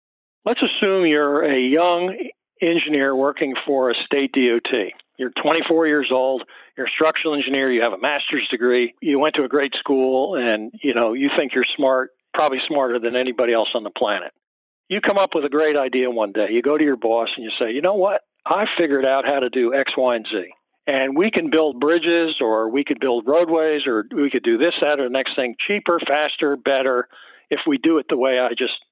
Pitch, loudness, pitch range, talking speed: 140 Hz, -19 LUFS, 130-160 Hz, 220 wpm